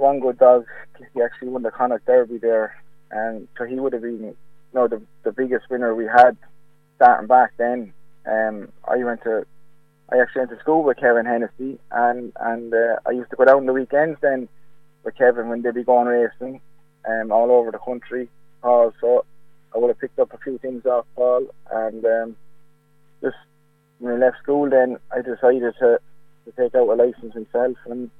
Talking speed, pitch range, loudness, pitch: 195 wpm, 120-150 Hz, -20 LUFS, 125 Hz